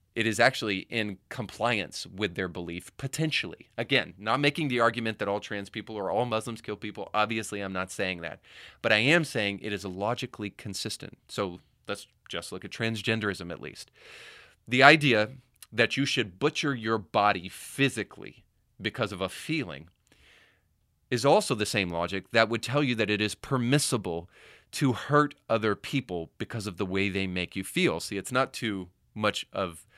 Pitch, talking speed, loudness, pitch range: 110 Hz, 175 wpm, -28 LUFS, 95-125 Hz